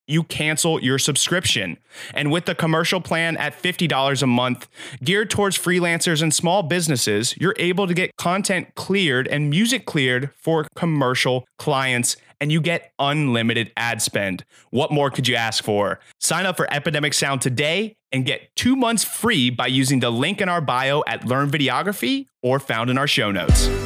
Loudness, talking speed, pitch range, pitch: -20 LUFS, 175 wpm, 130-175 Hz, 150 Hz